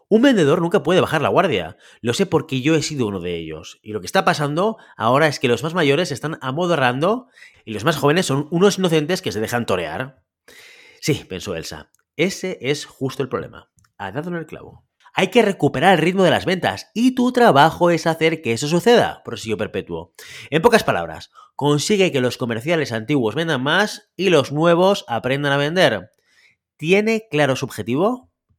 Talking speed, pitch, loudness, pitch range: 190 wpm, 155 Hz, -19 LUFS, 130-185 Hz